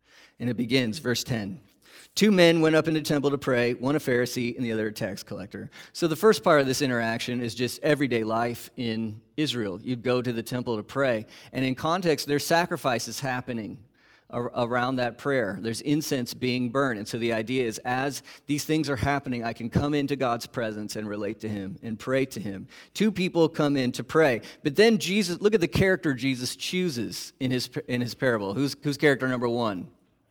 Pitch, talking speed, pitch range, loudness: 130 Hz, 210 wpm, 120-150 Hz, -26 LUFS